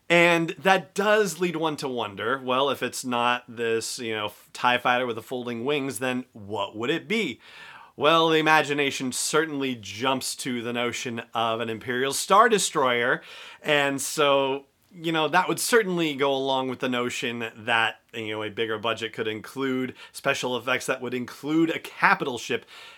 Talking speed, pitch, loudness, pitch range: 170 wpm, 130 Hz, -25 LUFS, 120-155 Hz